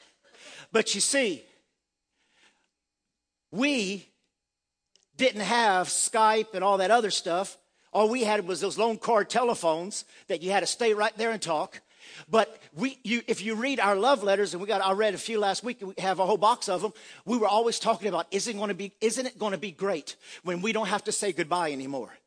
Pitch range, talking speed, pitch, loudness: 190-225 Hz, 210 wpm, 210 Hz, -27 LUFS